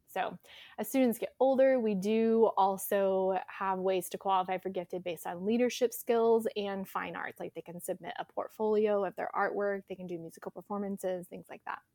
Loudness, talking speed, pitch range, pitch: -32 LUFS, 190 wpm, 185-220 Hz, 195 Hz